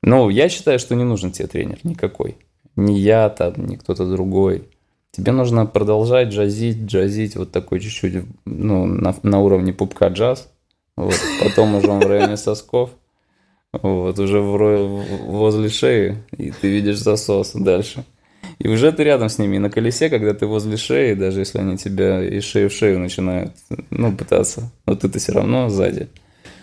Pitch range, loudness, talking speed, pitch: 95-110 Hz, -18 LUFS, 170 wpm, 105 Hz